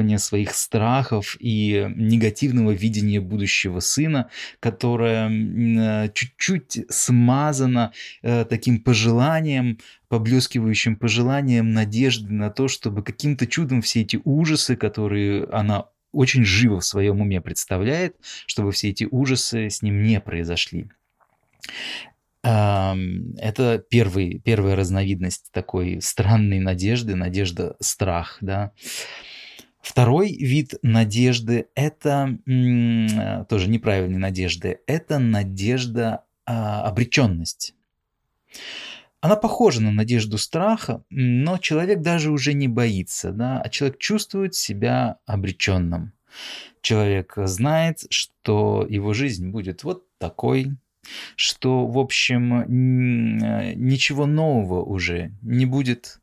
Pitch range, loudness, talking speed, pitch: 105-130 Hz, -21 LUFS, 100 wpm, 115 Hz